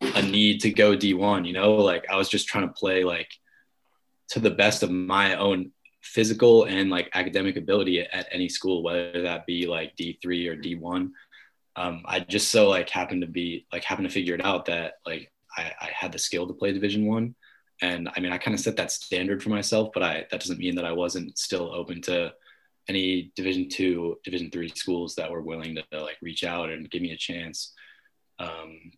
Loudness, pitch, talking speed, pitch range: -25 LUFS, 90 Hz, 225 wpm, 85-100 Hz